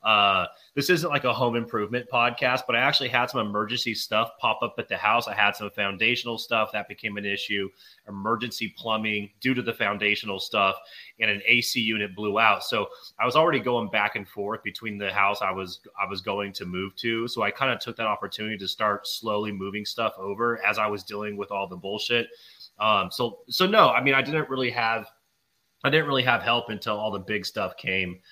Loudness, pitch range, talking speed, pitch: -25 LUFS, 100-120 Hz, 220 wpm, 110 Hz